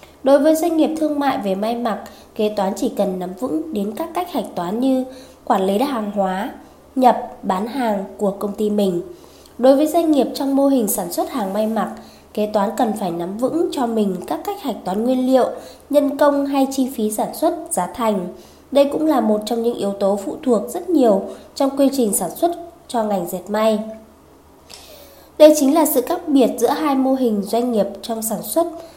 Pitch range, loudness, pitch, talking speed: 210-285 Hz, -19 LUFS, 240 Hz, 215 wpm